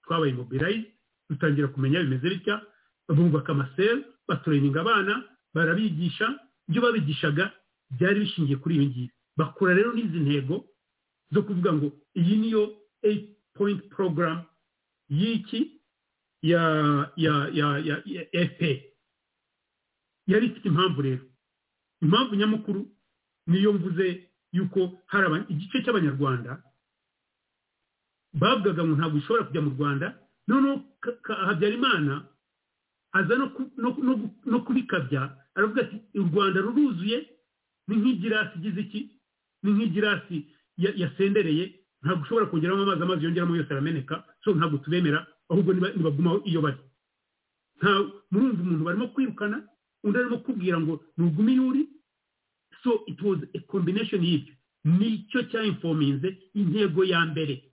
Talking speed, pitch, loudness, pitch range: 110 wpm, 185 Hz, -26 LUFS, 155-210 Hz